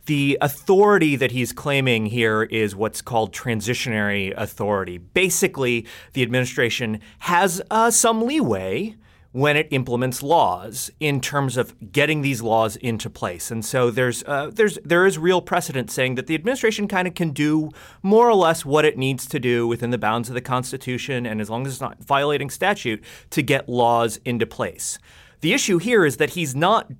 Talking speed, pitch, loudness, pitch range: 180 wpm, 130 Hz, -21 LUFS, 115-160 Hz